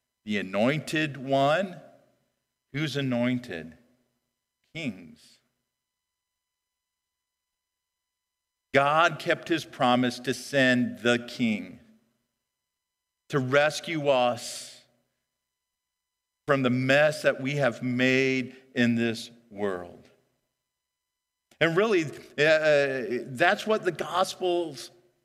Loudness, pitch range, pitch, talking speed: -26 LUFS, 115-155 Hz, 125 Hz, 80 wpm